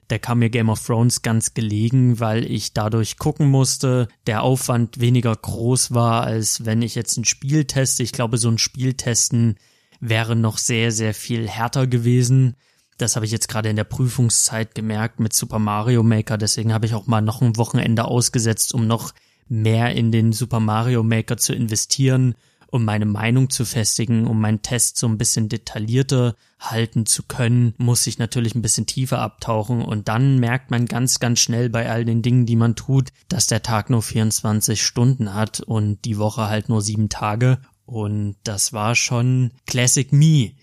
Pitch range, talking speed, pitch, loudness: 110-125 Hz, 185 wpm, 115 Hz, -19 LUFS